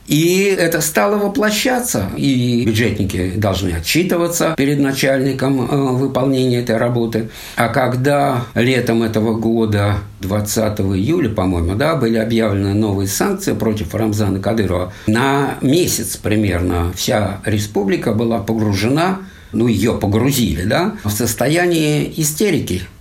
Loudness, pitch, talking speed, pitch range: -16 LUFS, 115 Hz, 110 wpm, 105-140 Hz